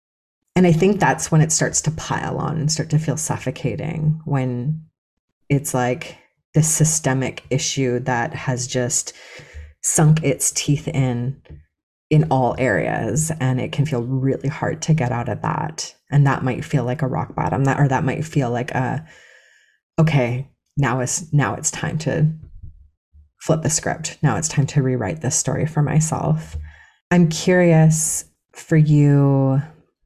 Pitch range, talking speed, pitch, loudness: 130-155 Hz, 160 wpm, 145 Hz, -19 LUFS